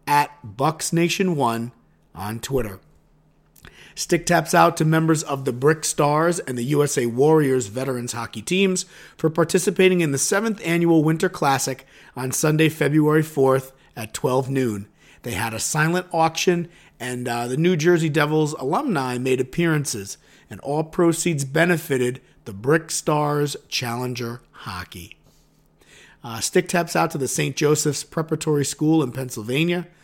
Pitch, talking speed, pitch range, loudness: 150 Hz, 145 wpm, 130-165 Hz, -21 LUFS